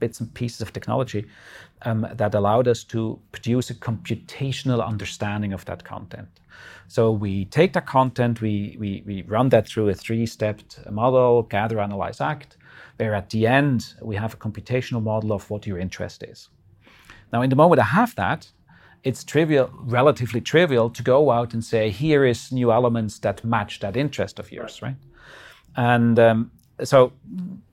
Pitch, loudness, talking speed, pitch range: 115 Hz, -22 LUFS, 170 wpm, 105-125 Hz